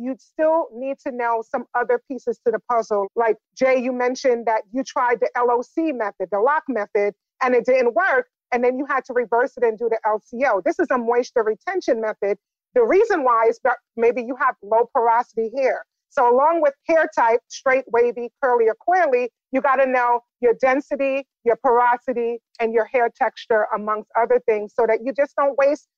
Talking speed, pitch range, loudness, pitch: 200 wpm, 230-275 Hz, -20 LUFS, 245 Hz